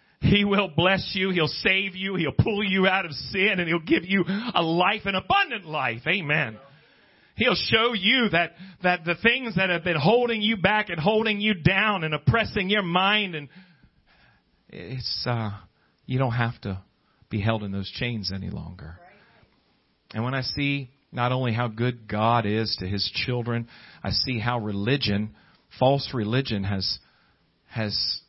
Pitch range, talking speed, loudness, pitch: 115-190 Hz, 170 wpm, -24 LUFS, 145 Hz